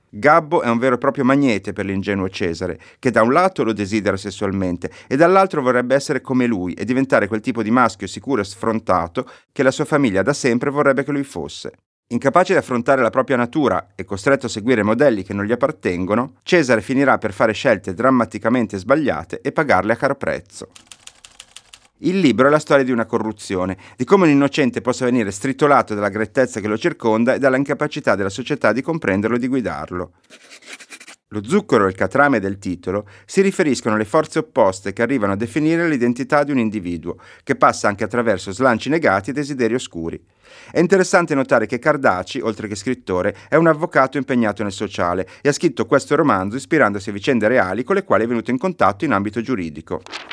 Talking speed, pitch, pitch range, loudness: 190 wpm, 120 Hz, 105-140 Hz, -18 LUFS